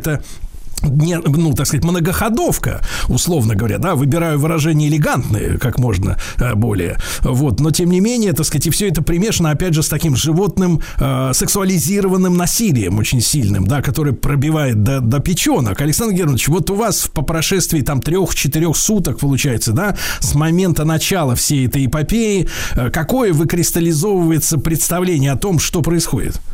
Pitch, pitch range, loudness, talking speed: 155 Hz, 135-175 Hz, -15 LUFS, 150 wpm